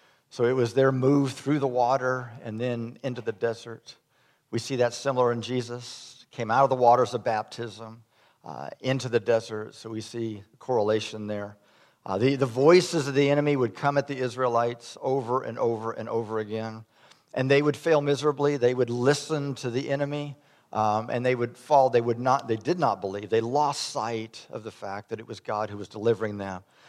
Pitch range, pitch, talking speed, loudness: 115-135 Hz, 120 Hz, 200 wpm, -26 LUFS